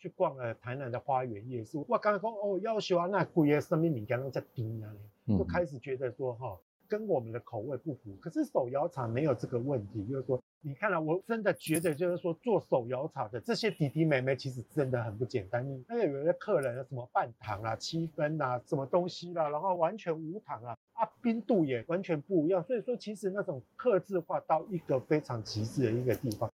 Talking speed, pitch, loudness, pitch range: 340 characters per minute, 150 Hz, -33 LUFS, 125-180 Hz